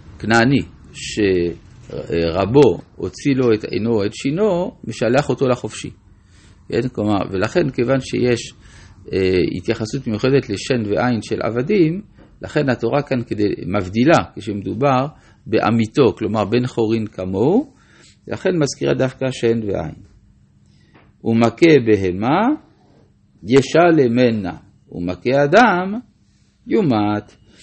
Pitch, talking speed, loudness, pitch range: 115 Hz, 95 wpm, -18 LUFS, 100-130 Hz